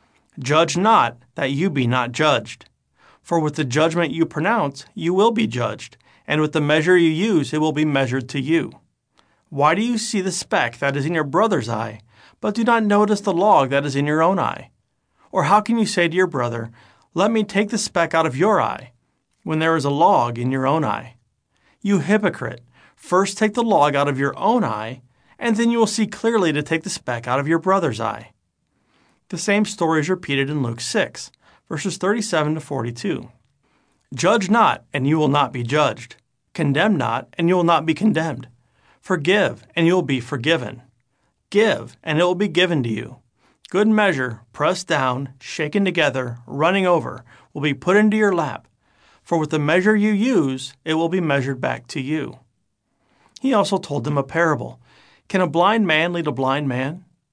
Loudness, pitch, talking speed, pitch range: -20 LUFS, 155 Hz, 195 wpm, 135-185 Hz